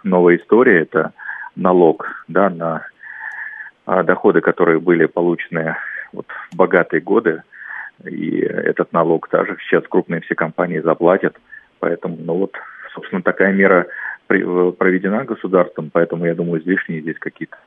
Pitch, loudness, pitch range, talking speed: 85 Hz, -17 LUFS, 85-95 Hz, 125 wpm